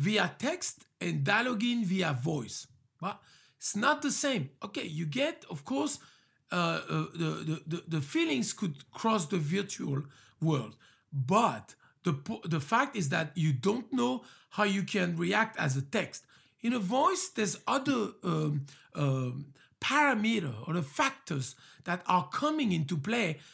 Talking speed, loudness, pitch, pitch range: 150 wpm, -31 LUFS, 180 Hz, 155-235 Hz